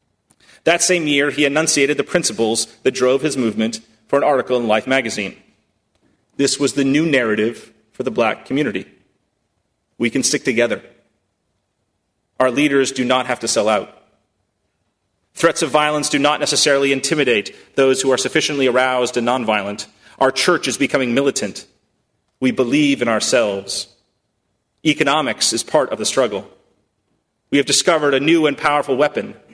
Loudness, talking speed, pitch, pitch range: -17 LUFS, 150 wpm, 130 Hz, 110-145 Hz